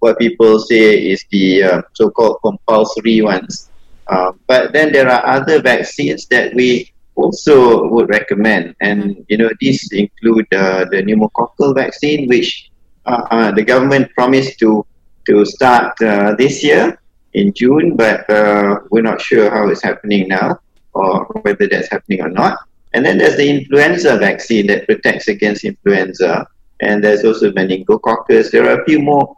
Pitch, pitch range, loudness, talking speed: 110 Hz, 100-130 Hz, -12 LUFS, 160 wpm